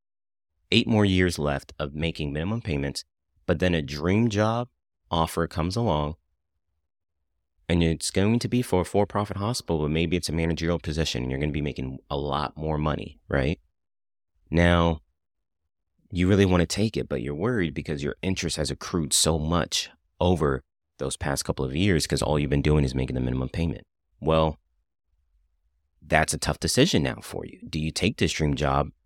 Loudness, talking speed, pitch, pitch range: -25 LUFS, 185 wpm, 80 Hz, 75-90 Hz